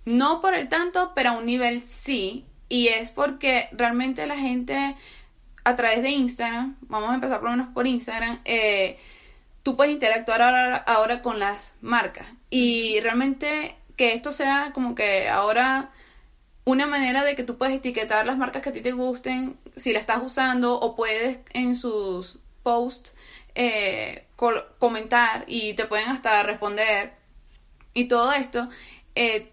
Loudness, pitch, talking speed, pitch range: -24 LUFS, 245 Hz, 160 wpm, 230-265 Hz